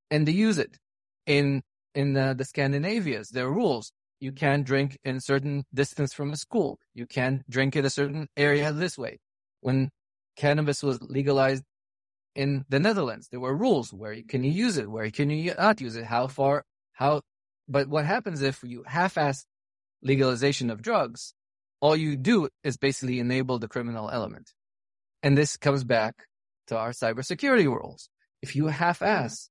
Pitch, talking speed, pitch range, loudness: 135 Hz, 170 wpm, 125-145 Hz, -27 LUFS